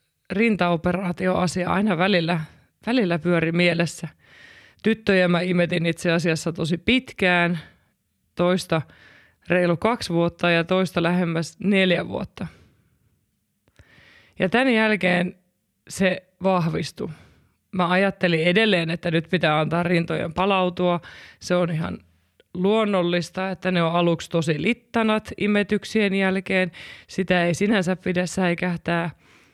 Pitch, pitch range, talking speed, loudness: 180 Hz, 170-190 Hz, 110 wpm, -22 LUFS